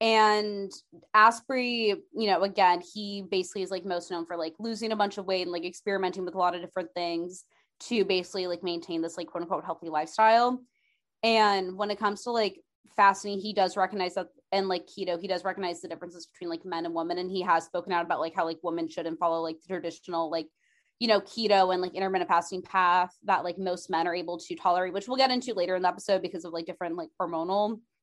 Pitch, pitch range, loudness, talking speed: 185 Hz, 175-200 Hz, -28 LUFS, 230 wpm